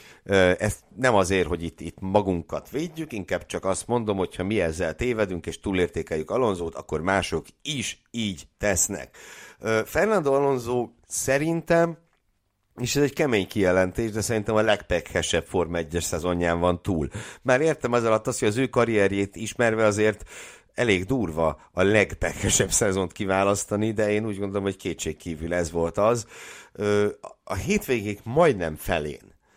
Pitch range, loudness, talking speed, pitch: 90-120 Hz, -25 LUFS, 145 wpm, 105 Hz